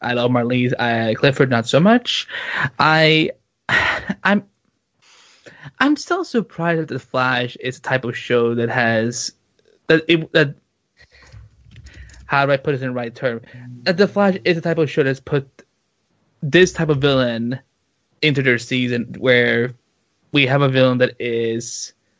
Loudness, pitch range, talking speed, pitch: -18 LUFS, 120-160 Hz, 160 wpm, 130 Hz